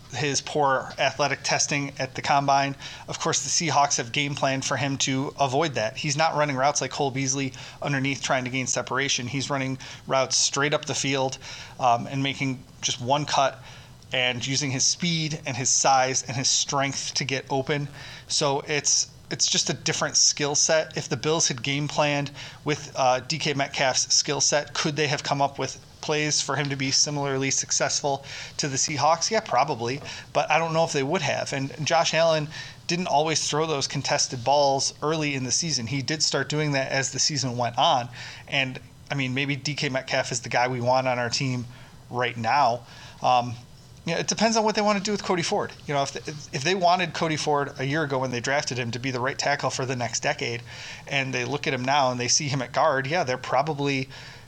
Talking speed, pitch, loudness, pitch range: 215 wpm, 140 Hz, -24 LUFS, 130-150 Hz